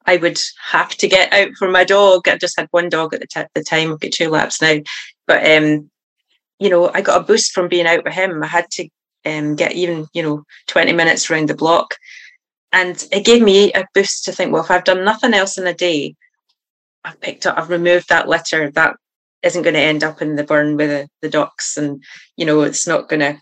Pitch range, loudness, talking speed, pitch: 155-185 Hz, -15 LUFS, 240 wpm, 175 Hz